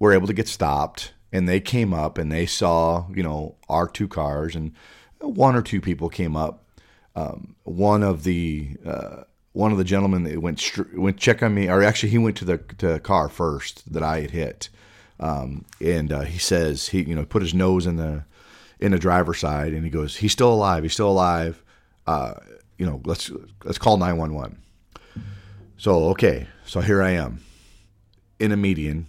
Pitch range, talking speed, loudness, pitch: 80-100 Hz, 200 wpm, -22 LUFS, 90 Hz